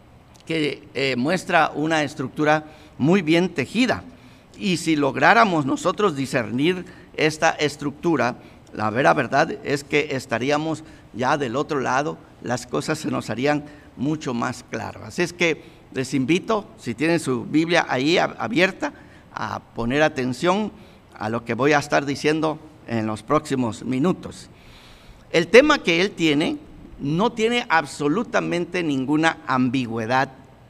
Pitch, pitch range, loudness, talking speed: 150 Hz, 130-165 Hz, -22 LUFS, 135 wpm